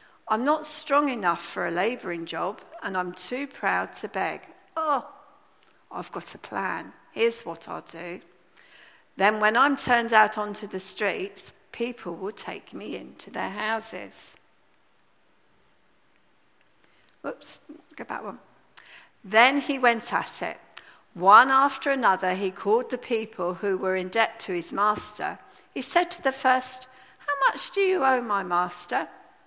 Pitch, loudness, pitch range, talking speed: 240 Hz, -25 LUFS, 195-285 Hz, 150 wpm